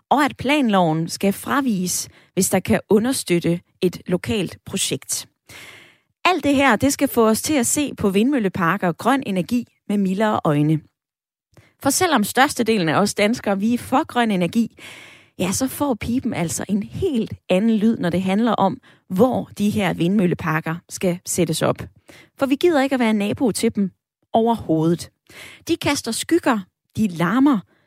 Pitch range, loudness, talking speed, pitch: 180-260 Hz, -20 LUFS, 165 wpm, 215 Hz